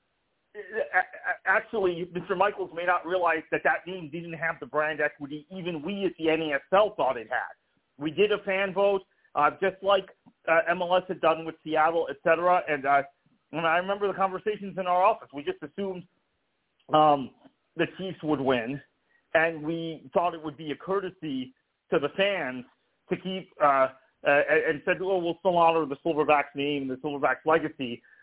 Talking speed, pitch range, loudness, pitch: 180 wpm, 150-190 Hz, -27 LUFS, 165 Hz